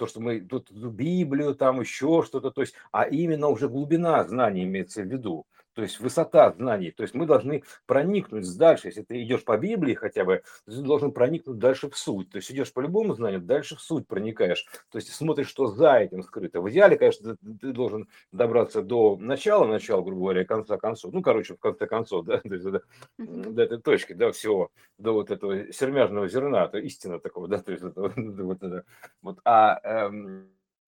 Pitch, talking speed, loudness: 130 Hz, 205 wpm, -25 LUFS